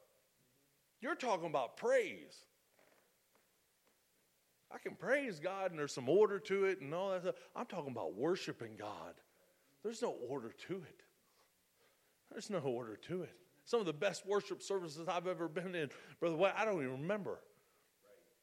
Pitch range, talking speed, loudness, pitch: 165-205 Hz, 160 wpm, -40 LUFS, 185 Hz